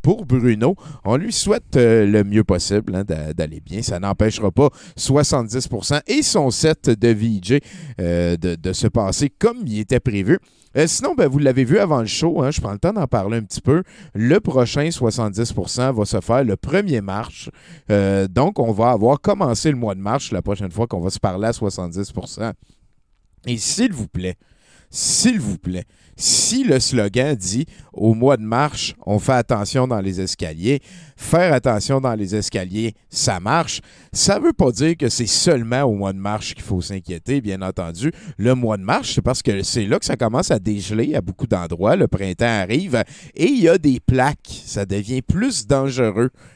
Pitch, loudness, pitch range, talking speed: 120 Hz, -19 LUFS, 100-140 Hz, 195 wpm